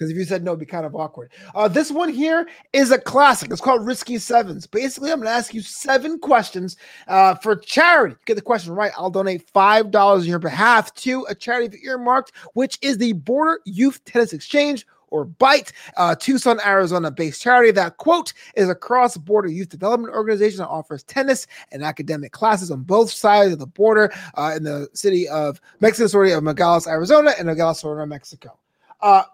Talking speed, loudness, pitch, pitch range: 195 wpm, -18 LUFS, 210 Hz, 170-255 Hz